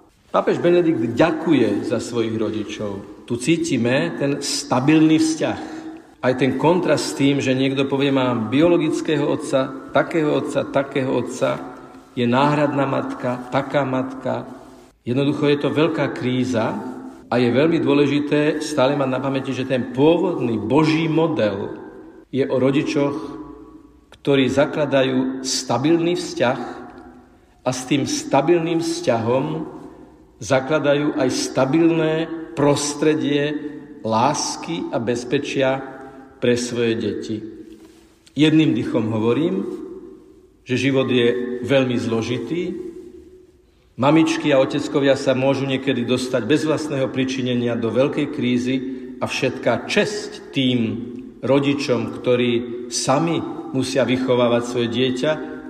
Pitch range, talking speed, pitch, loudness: 125-155 Hz, 110 wpm, 135 Hz, -20 LUFS